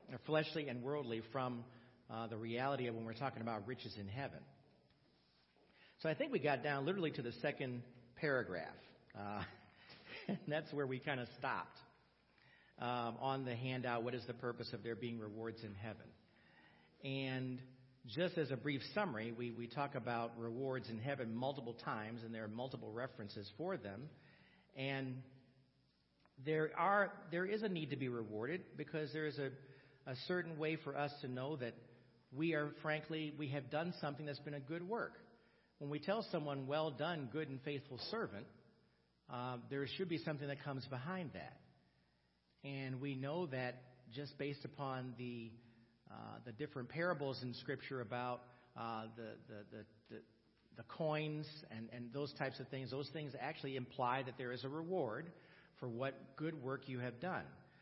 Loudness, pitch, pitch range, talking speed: -44 LUFS, 135 Hz, 120-150 Hz, 175 wpm